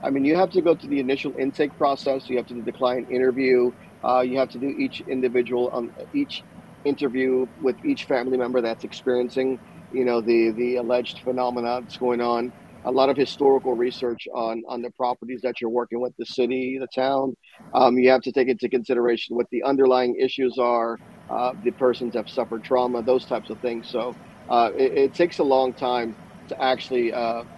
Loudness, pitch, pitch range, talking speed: -23 LUFS, 125 Hz, 120-130 Hz, 205 wpm